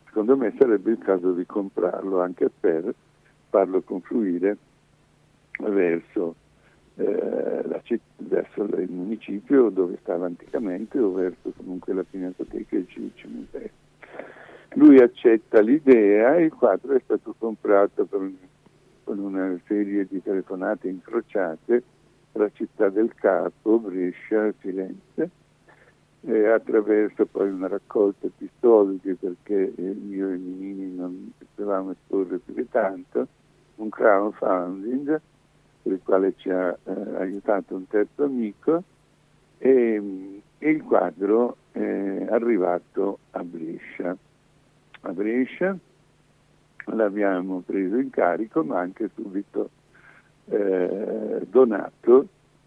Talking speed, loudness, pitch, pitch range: 120 wpm, -23 LUFS, 105 Hz, 95-155 Hz